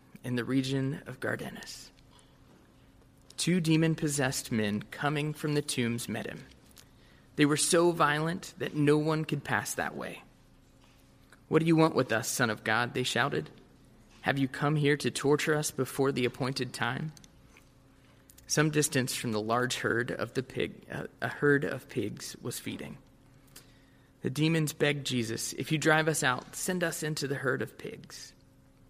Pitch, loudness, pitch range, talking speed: 140 Hz, -30 LUFS, 125-155 Hz, 160 wpm